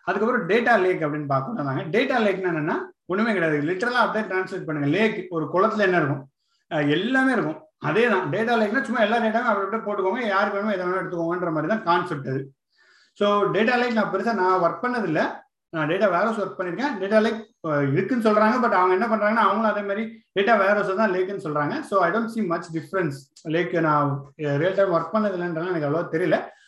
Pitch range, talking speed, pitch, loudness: 165-220 Hz, 155 wpm, 195 Hz, -23 LUFS